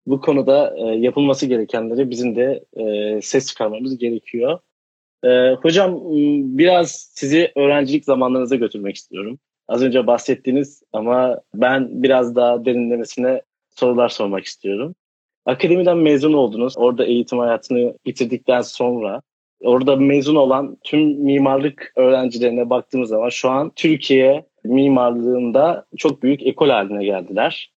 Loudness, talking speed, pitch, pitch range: -17 LUFS, 110 wpm, 130 Hz, 120-140 Hz